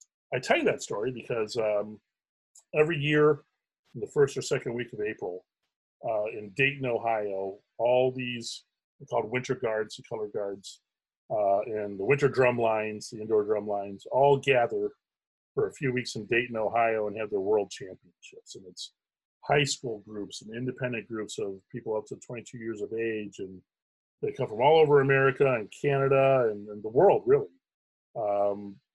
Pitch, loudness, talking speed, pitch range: 120 Hz, -28 LUFS, 175 wpm, 105-145 Hz